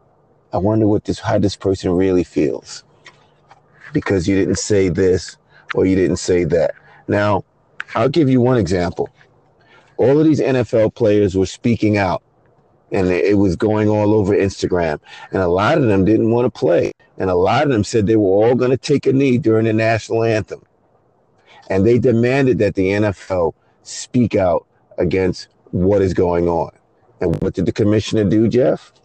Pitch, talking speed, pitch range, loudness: 105 Hz, 180 wpm, 95-115 Hz, -17 LUFS